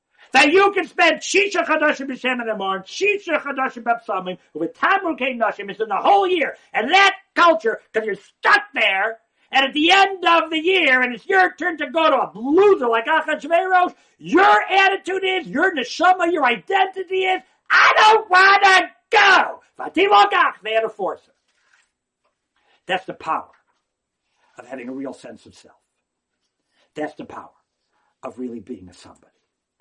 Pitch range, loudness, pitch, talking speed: 245-380 Hz, -17 LUFS, 335 Hz, 165 wpm